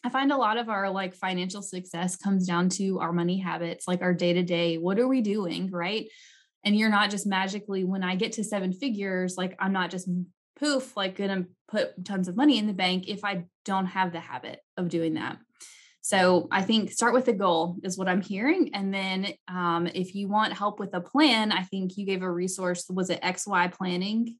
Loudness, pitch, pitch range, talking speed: -27 LUFS, 190 Hz, 180-205 Hz, 225 wpm